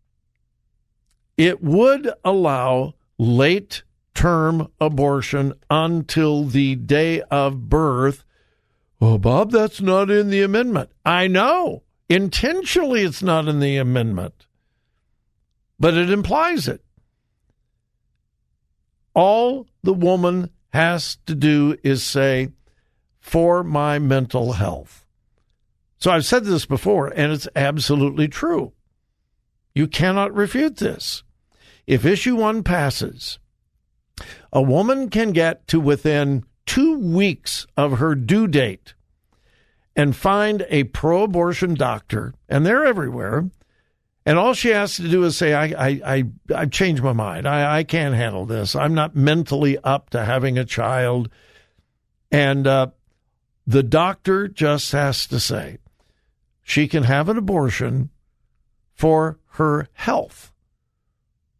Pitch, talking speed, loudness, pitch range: 150 Hz, 120 wpm, -19 LUFS, 130-180 Hz